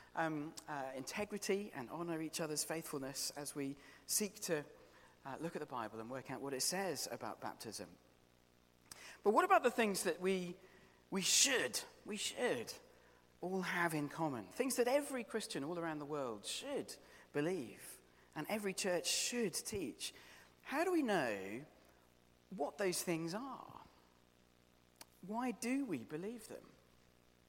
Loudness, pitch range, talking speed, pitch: -40 LUFS, 130-205 Hz, 150 wpm, 165 Hz